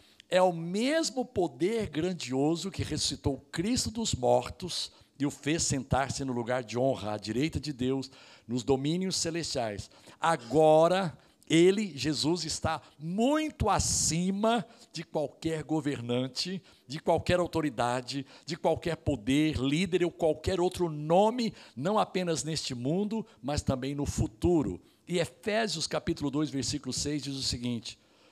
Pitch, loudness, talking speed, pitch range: 155 Hz, -30 LUFS, 130 wpm, 135-175 Hz